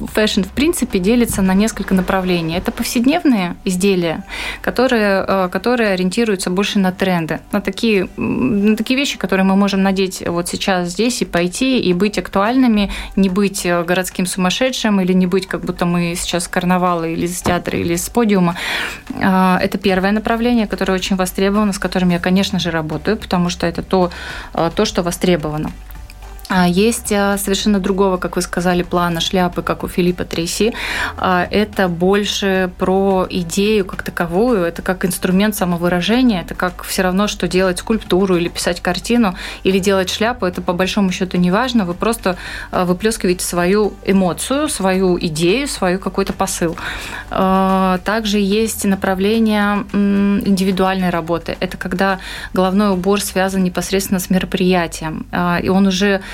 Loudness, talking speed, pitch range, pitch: -16 LUFS, 145 wpm, 180-205 Hz, 190 Hz